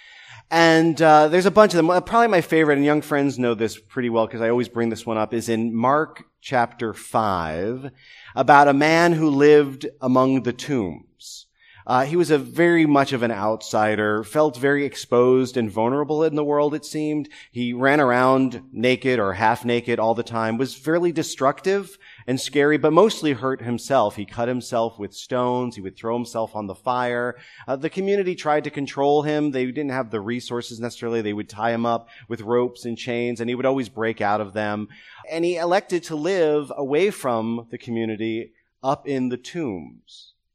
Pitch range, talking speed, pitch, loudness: 115-150 Hz, 190 wpm, 125 Hz, -21 LUFS